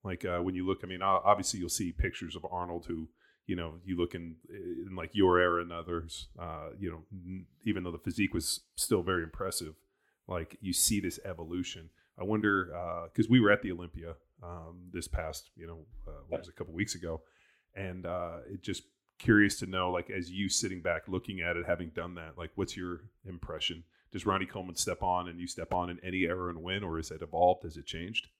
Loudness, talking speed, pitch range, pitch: -33 LUFS, 225 wpm, 85-95 Hz, 90 Hz